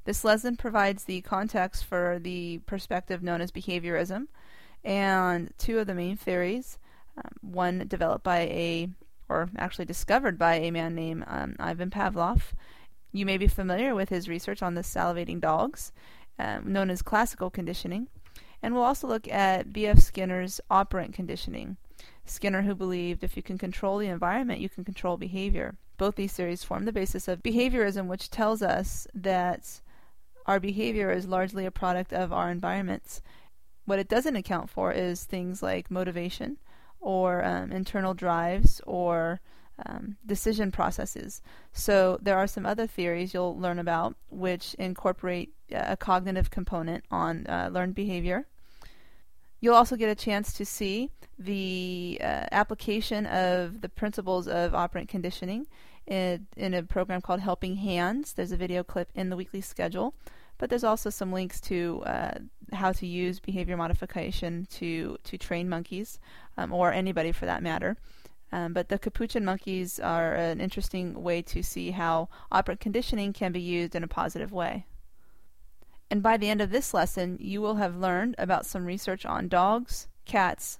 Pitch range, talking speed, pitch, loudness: 180-205 Hz, 160 wpm, 185 Hz, -30 LUFS